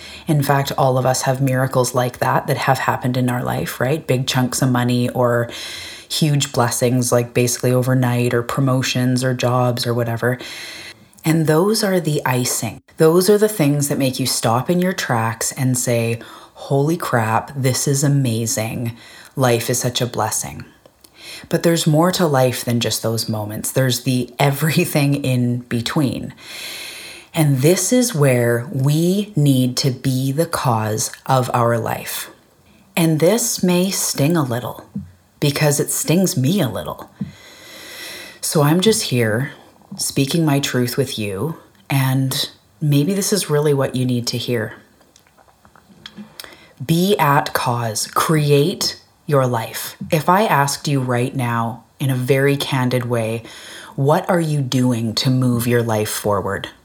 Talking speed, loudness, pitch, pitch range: 150 wpm, -18 LUFS, 130 Hz, 120-150 Hz